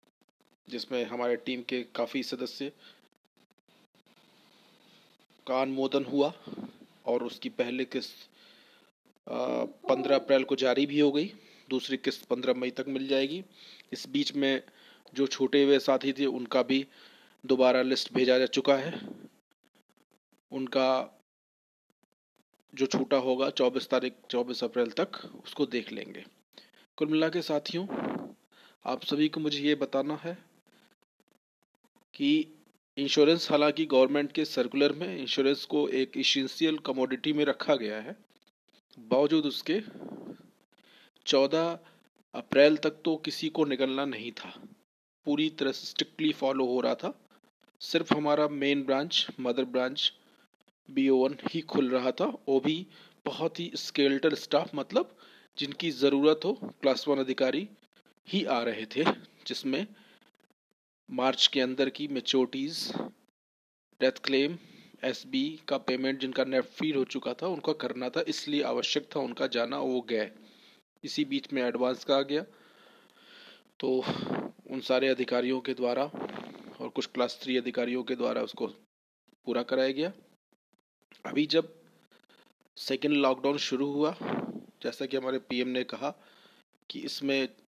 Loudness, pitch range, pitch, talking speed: -29 LUFS, 130-155 Hz, 135 Hz, 130 wpm